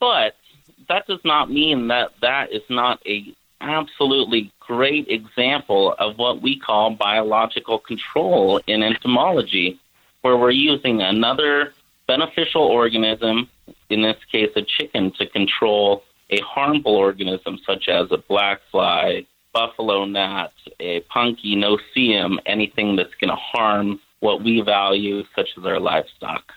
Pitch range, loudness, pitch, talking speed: 100-130 Hz, -19 LUFS, 110 Hz, 135 wpm